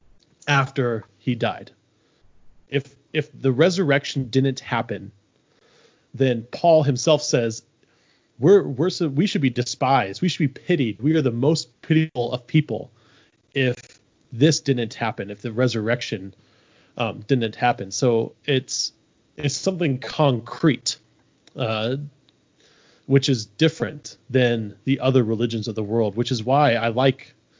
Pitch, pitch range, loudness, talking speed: 130 Hz, 115-145 Hz, -22 LUFS, 135 wpm